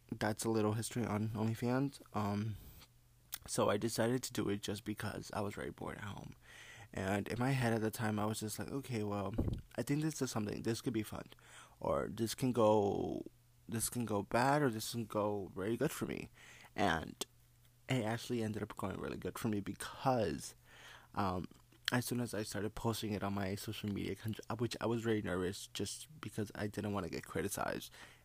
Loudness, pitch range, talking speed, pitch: -39 LUFS, 105-120 Hz, 205 wpm, 110 Hz